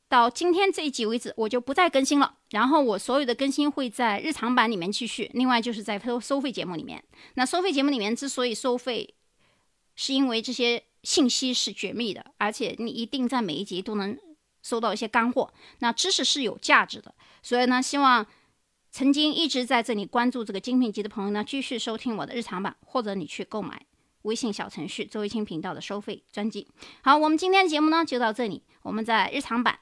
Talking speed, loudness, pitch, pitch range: 330 characters per minute, -25 LUFS, 240 Hz, 220-275 Hz